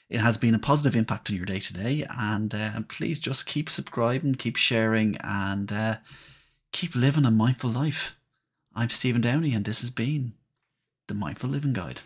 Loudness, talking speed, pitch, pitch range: -27 LUFS, 185 wpm, 120 Hz, 110-140 Hz